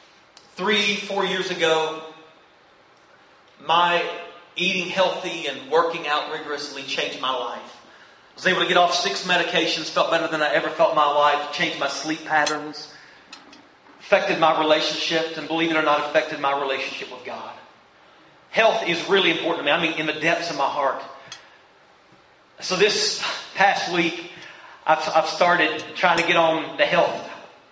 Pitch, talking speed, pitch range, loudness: 165 Hz, 160 wpm, 155-180 Hz, -21 LUFS